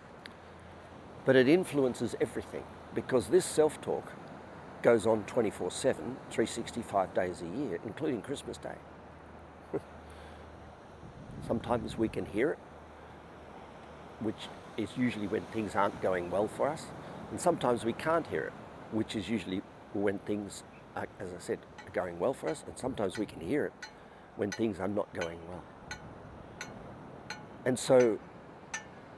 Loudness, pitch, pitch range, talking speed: -33 LUFS, 100 Hz, 85-115 Hz, 140 wpm